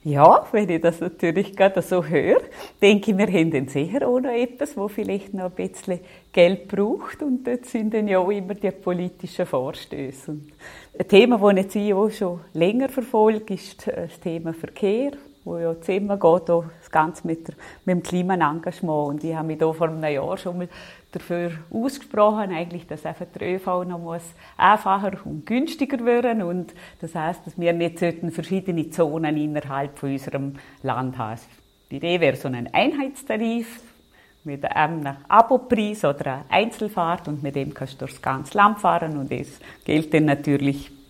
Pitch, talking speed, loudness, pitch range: 175 Hz, 180 wpm, -22 LUFS, 155-205 Hz